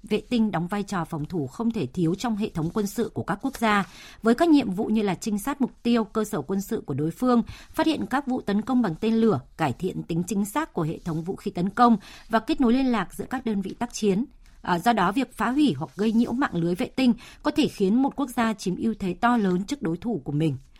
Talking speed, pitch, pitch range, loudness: 275 wpm, 215 Hz, 185-240 Hz, -25 LUFS